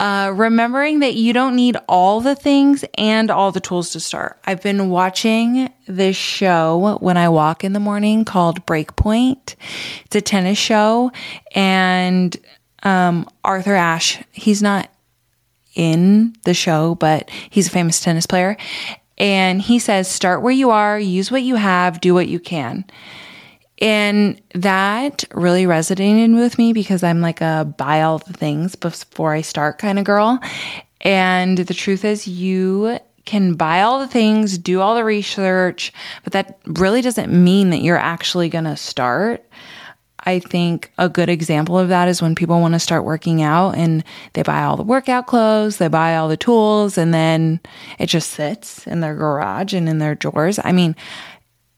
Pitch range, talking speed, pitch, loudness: 170-210 Hz, 170 wpm, 185 Hz, -16 LUFS